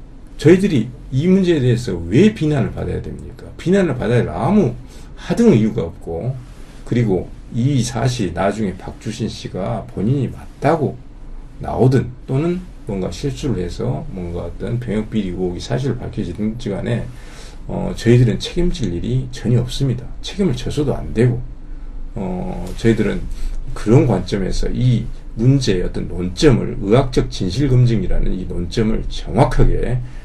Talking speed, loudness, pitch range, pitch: 300 characters per minute, -18 LUFS, 105-140 Hz, 120 Hz